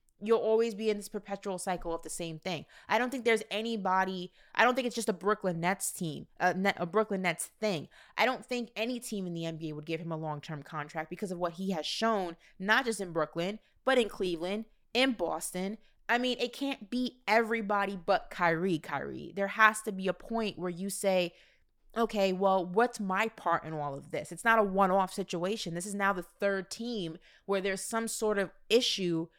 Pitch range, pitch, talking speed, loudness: 175-220 Hz, 195 Hz, 215 wpm, -32 LUFS